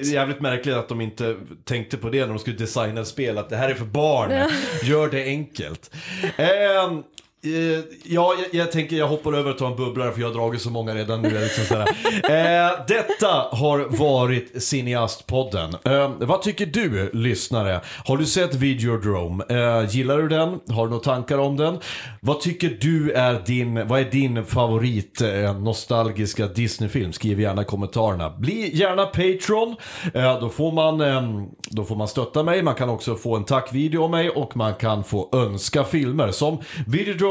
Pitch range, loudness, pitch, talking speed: 115-155 Hz, -22 LUFS, 130 Hz, 190 wpm